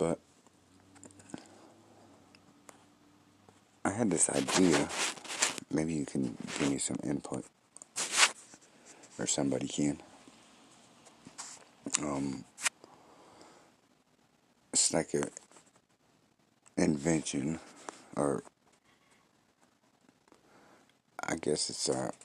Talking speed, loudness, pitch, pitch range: 65 wpm, -32 LUFS, 80 Hz, 75-95 Hz